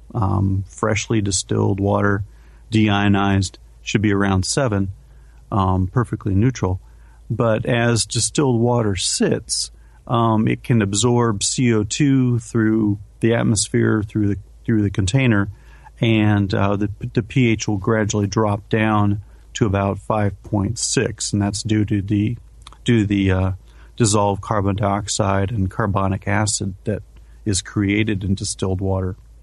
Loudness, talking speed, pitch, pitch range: -19 LUFS, 130 wpm, 105 Hz, 100-115 Hz